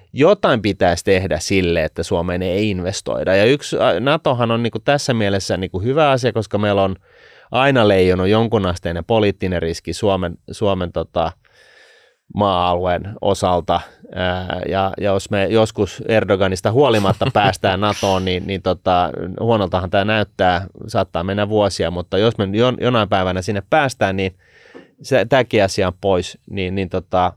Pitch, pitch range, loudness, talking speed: 95 Hz, 90-110 Hz, -18 LUFS, 145 wpm